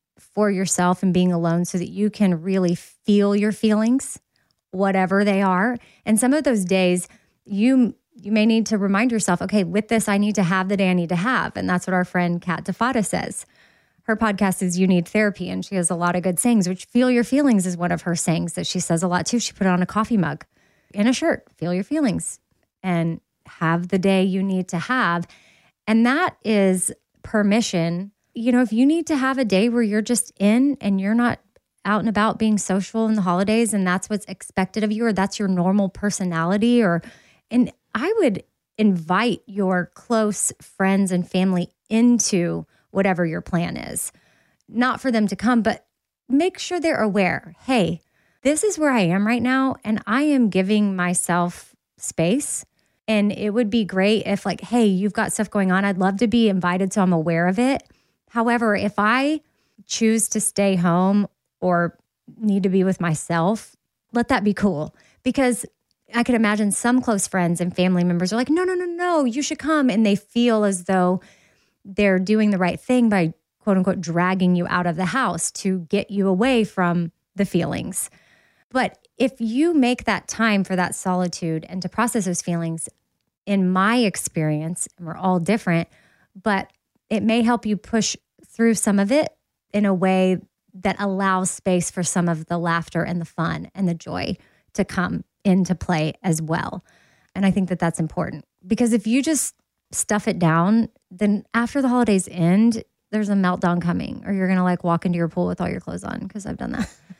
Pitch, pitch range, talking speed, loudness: 200 Hz, 180-230 Hz, 200 wpm, -21 LUFS